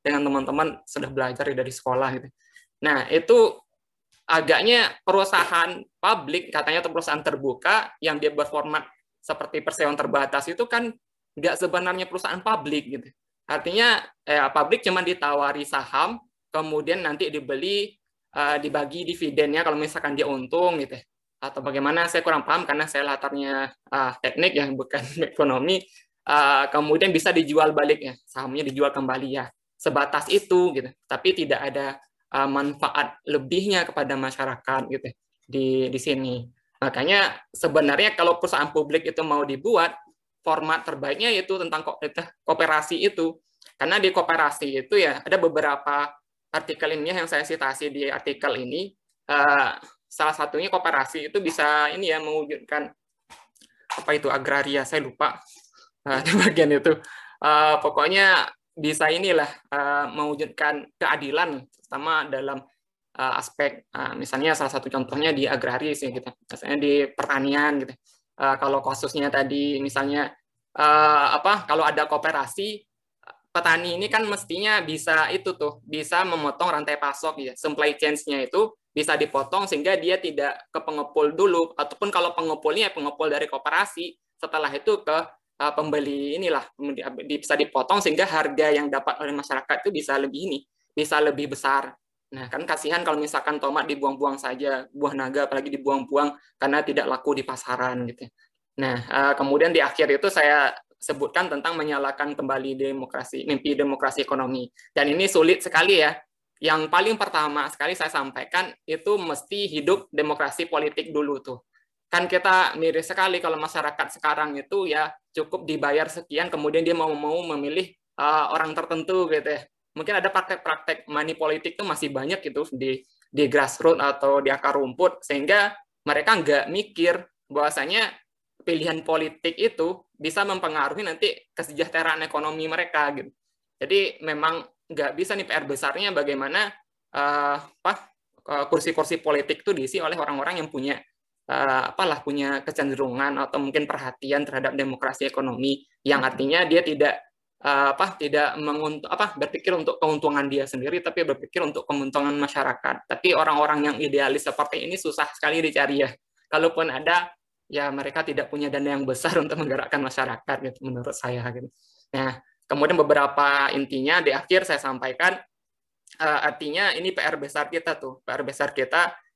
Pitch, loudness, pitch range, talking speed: 150 Hz, -23 LUFS, 140-165 Hz, 150 wpm